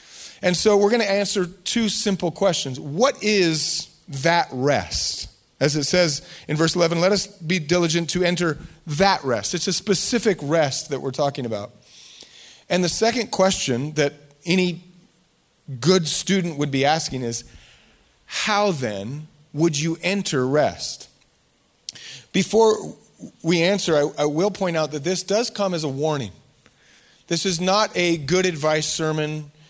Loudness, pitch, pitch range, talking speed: -21 LUFS, 170 Hz, 150-190 Hz, 150 wpm